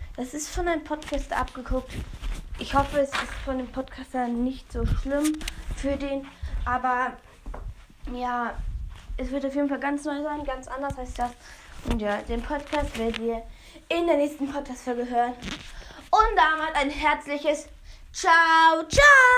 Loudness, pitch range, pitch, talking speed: -25 LUFS, 250-295 Hz, 280 Hz, 150 wpm